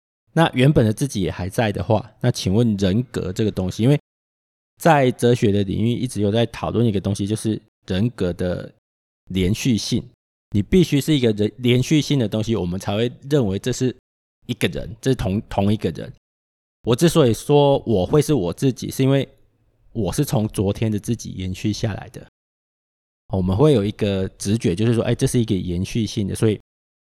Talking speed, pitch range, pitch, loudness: 280 characters per minute, 95-125 Hz, 110 Hz, -20 LUFS